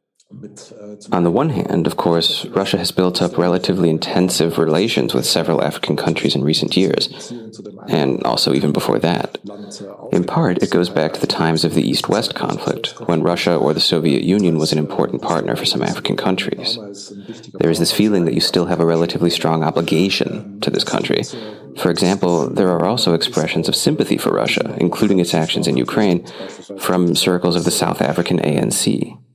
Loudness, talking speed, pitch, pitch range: -17 LUFS, 180 wpm, 85 Hz, 80-95 Hz